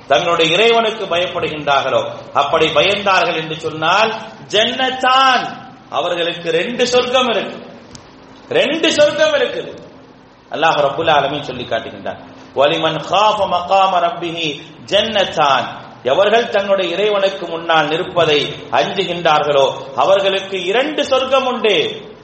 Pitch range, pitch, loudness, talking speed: 165-240 Hz, 195 Hz, -15 LUFS, 90 wpm